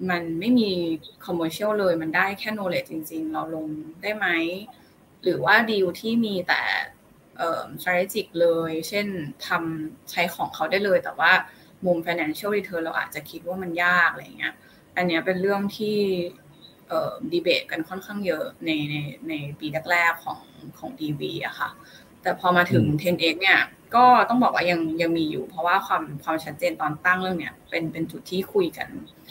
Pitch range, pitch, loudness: 160-200 Hz, 175 Hz, -24 LUFS